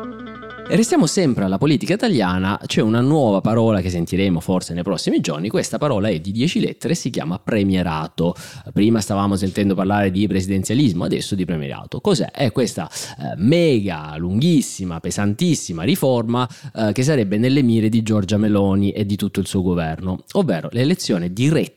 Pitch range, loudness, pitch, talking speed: 95-125 Hz, -19 LUFS, 105 Hz, 155 wpm